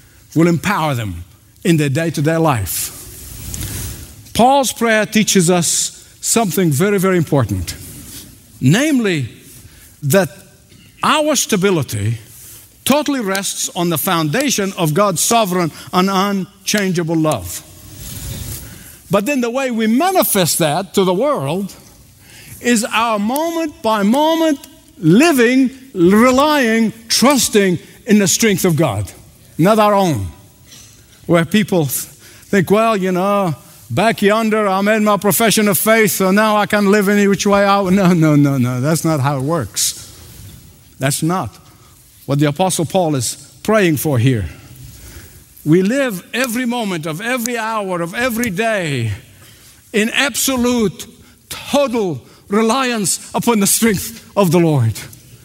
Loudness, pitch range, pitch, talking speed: -15 LUFS, 130-220 Hz, 185 Hz, 130 wpm